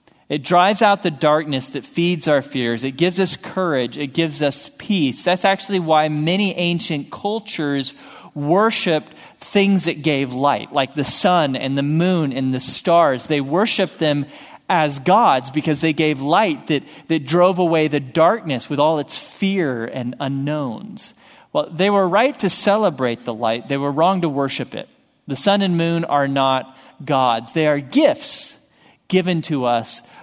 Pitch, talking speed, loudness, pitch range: 155 Hz, 170 wpm, -19 LUFS, 140-190 Hz